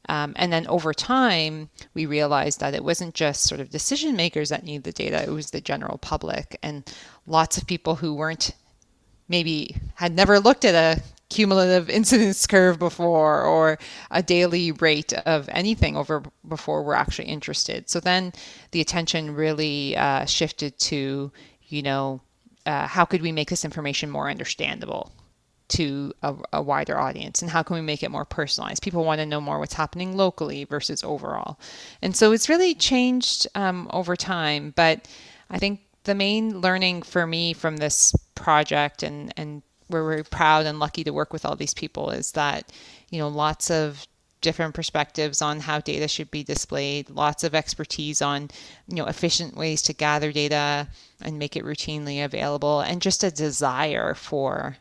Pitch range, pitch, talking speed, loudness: 150-175 Hz, 155 Hz, 175 wpm, -23 LUFS